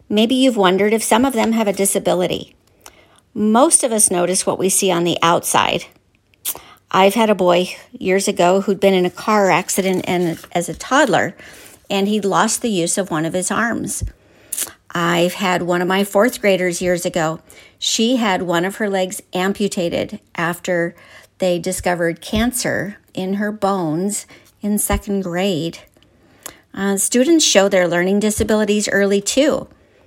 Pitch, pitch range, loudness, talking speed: 195 Hz, 180-210 Hz, -17 LUFS, 160 wpm